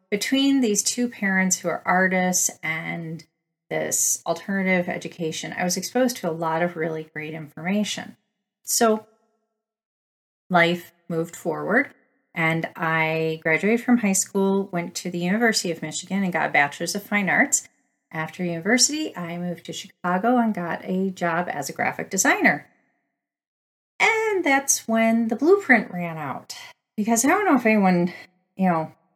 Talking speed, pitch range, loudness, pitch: 150 wpm, 170-225 Hz, -22 LUFS, 185 Hz